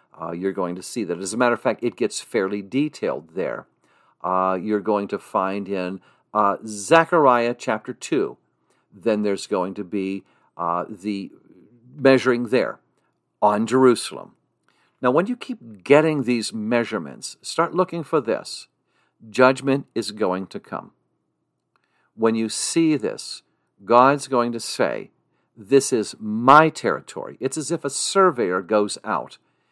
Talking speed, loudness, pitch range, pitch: 145 wpm, -21 LUFS, 100-140 Hz, 115 Hz